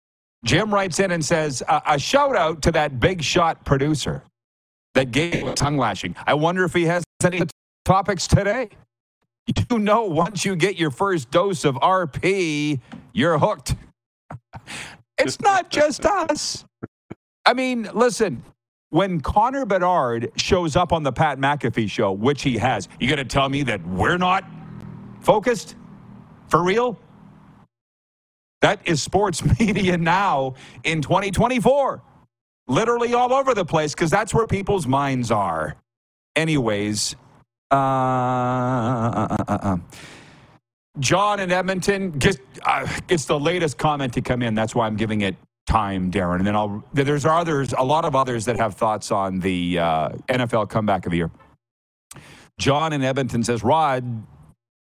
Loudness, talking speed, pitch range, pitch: -21 LUFS, 150 wpm, 120-180 Hz, 150 Hz